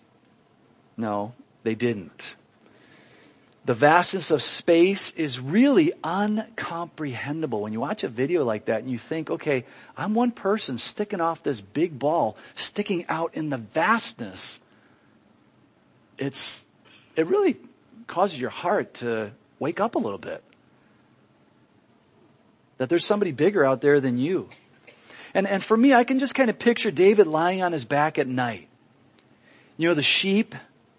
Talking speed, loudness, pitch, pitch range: 145 wpm, -24 LUFS, 165 Hz, 135-210 Hz